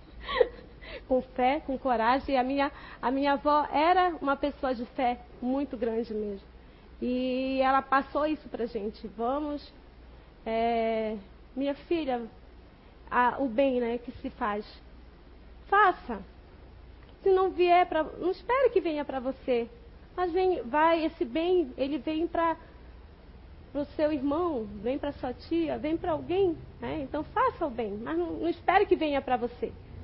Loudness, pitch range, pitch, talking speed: -29 LUFS, 250-330 Hz, 280 Hz, 155 wpm